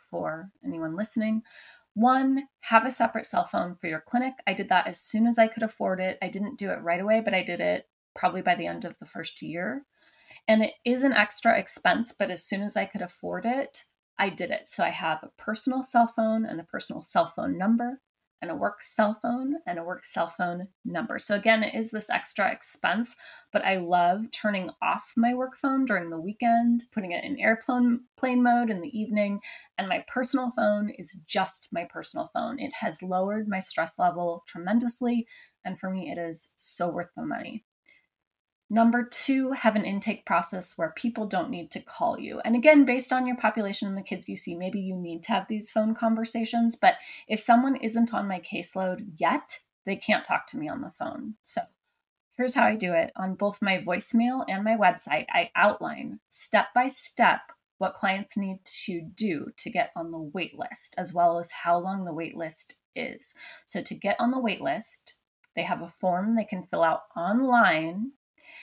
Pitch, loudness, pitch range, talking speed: 215 Hz, -27 LUFS, 185-240 Hz, 205 wpm